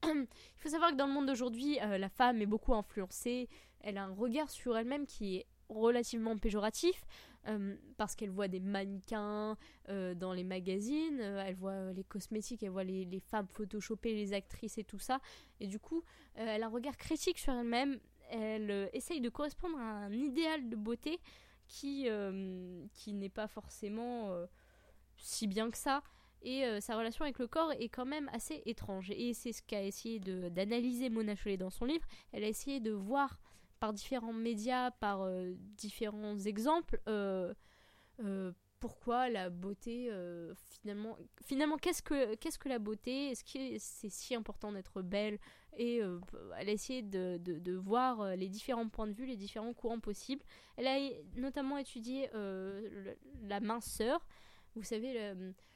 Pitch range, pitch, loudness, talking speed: 200-255 Hz, 220 Hz, -40 LUFS, 180 wpm